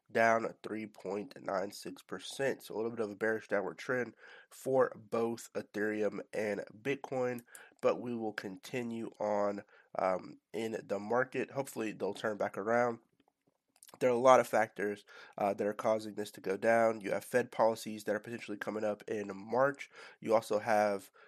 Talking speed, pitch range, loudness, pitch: 165 wpm, 105-120 Hz, -35 LUFS, 110 Hz